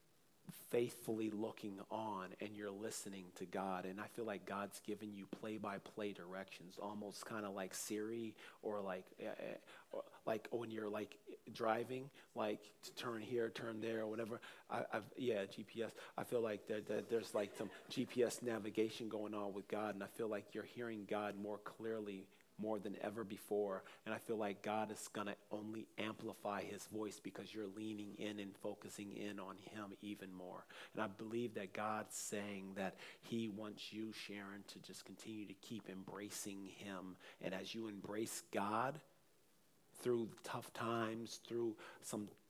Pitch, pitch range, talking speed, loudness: 105 Hz, 100-110 Hz, 170 wpm, -47 LUFS